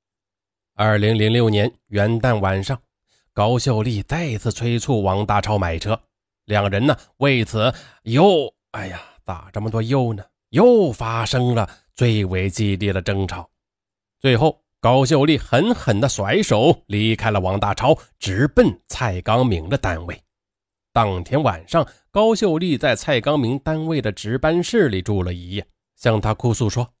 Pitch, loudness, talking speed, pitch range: 110 Hz, -19 LUFS, 215 characters per minute, 100-130 Hz